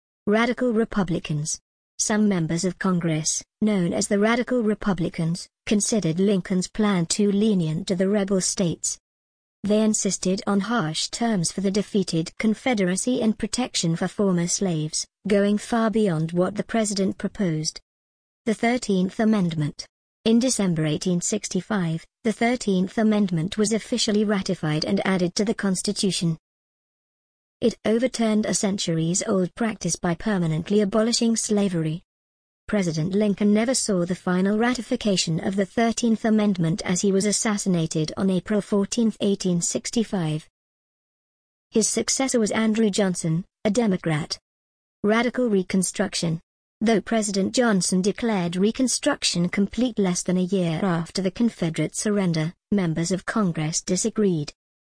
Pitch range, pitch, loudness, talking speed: 175-220 Hz, 200 Hz, -23 LUFS, 125 wpm